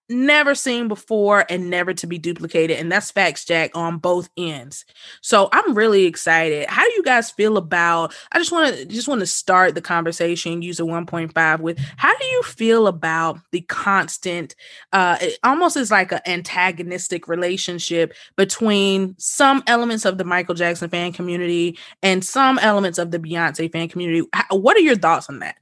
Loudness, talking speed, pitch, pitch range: -18 LUFS, 180 wpm, 180 Hz, 170-215 Hz